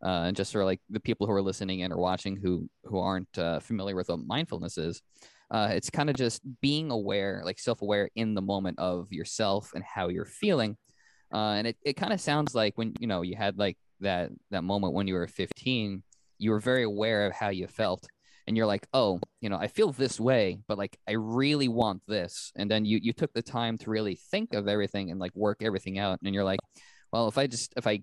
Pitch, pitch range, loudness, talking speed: 105 Hz, 95-115 Hz, -30 LUFS, 240 wpm